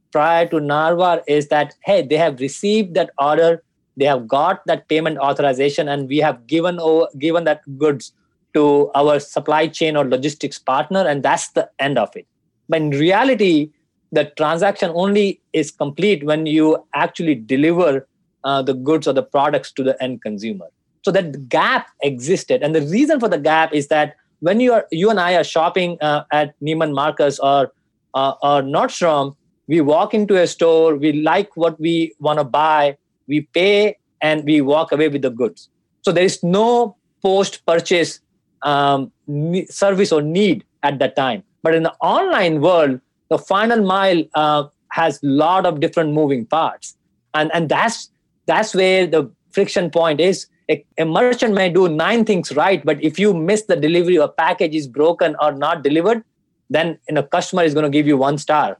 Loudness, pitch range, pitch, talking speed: -17 LUFS, 150-180 Hz, 160 Hz, 185 wpm